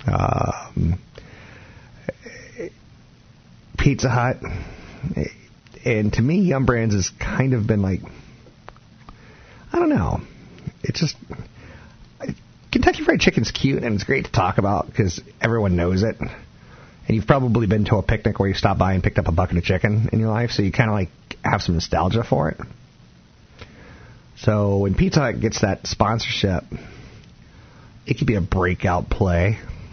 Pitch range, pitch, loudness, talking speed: 95-120 Hz, 110 Hz, -21 LUFS, 150 wpm